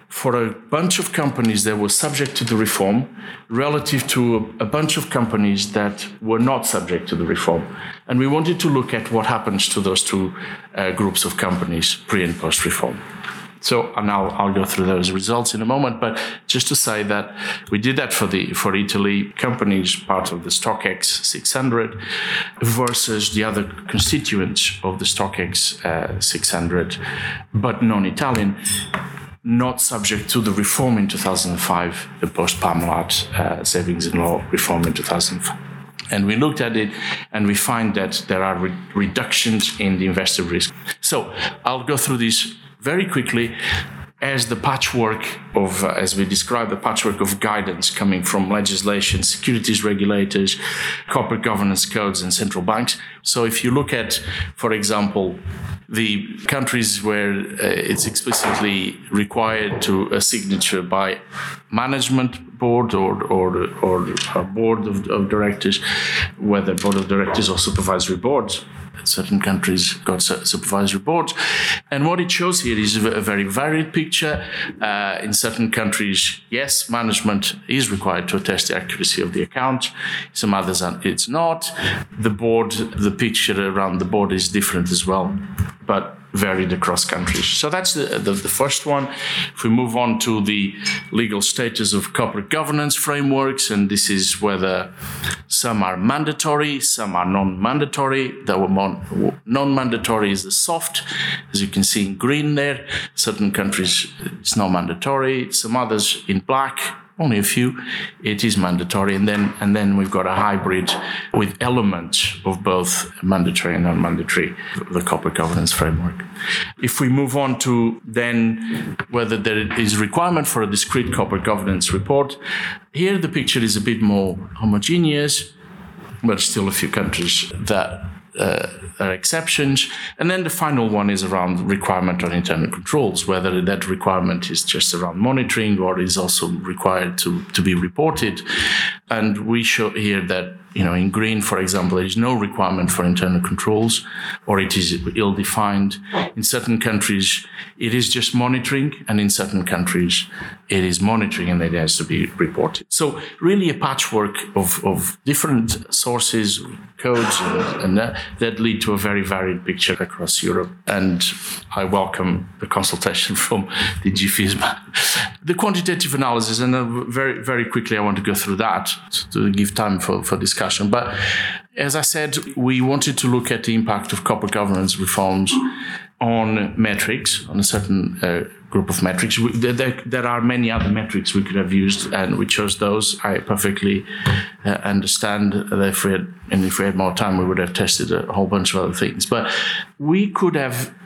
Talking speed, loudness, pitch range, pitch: 165 wpm, -19 LUFS, 95-125 Hz, 105 Hz